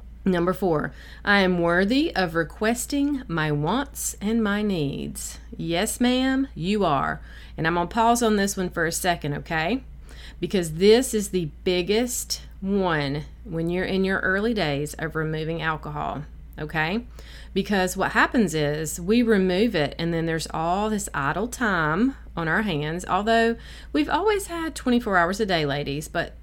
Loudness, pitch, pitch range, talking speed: -24 LUFS, 185 Hz, 160-220 Hz, 160 wpm